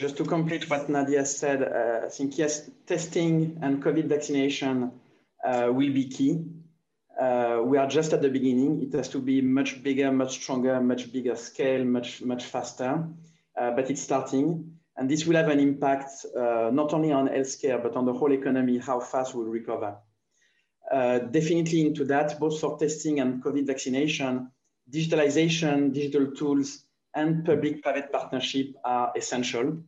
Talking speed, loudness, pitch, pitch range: 165 wpm, -26 LUFS, 140 Hz, 130-150 Hz